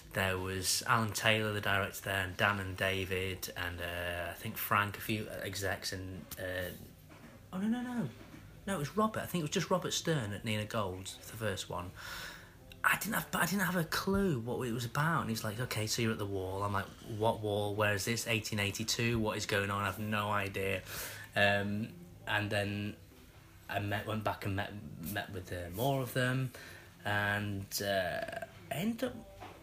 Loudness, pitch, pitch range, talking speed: -35 LUFS, 105 Hz, 95-115 Hz, 200 wpm